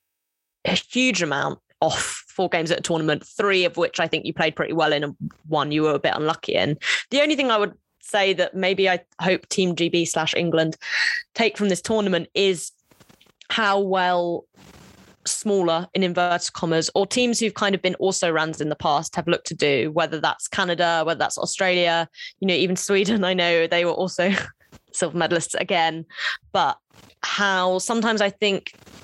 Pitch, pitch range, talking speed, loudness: 180 Hz, 165-195 Hz, 185 wpm, -22 LUFS